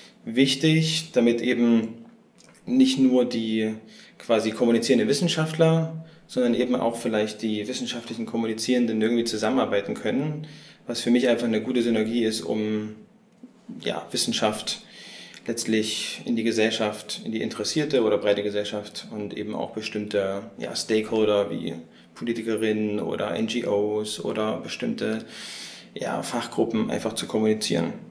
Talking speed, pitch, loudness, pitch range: 120 wpm, 115 Hz, -25 LUFS, 110-125 Hz